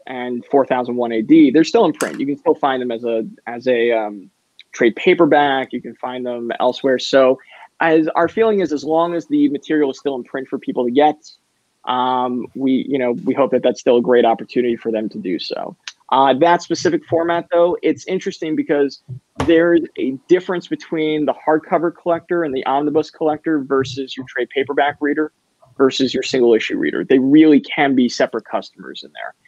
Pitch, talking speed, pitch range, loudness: 140 Hz, 195 wpm, 125-165 Hz, -17 LUFS